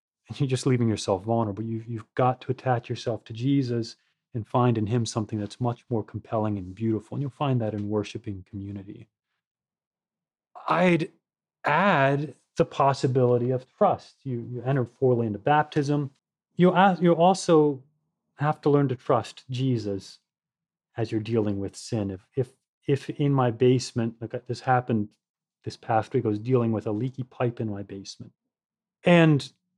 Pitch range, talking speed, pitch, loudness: 110-140 Hz, 165 wpm, 125 Hz, -25 LUFS